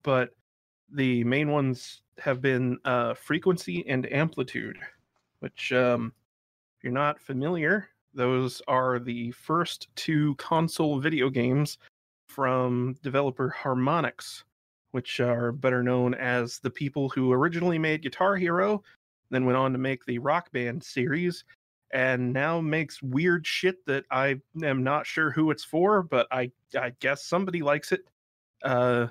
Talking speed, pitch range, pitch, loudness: 140 wpm, 125-155 Hz, 135 Hz, -27 LUFS